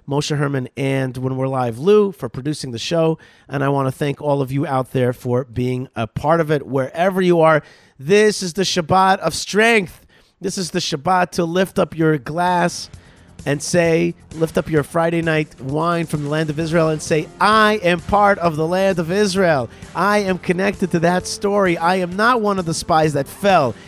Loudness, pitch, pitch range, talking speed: -18 LUFS, 165 Hz, 140-185 Hz, 210 wpm